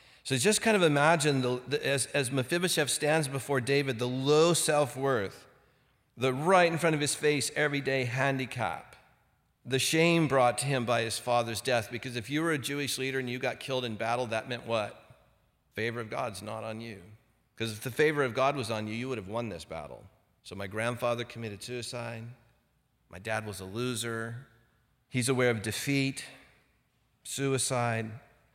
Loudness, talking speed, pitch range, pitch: -29 LUFS, 185 wpm, 115-140 Hz, 125 Hz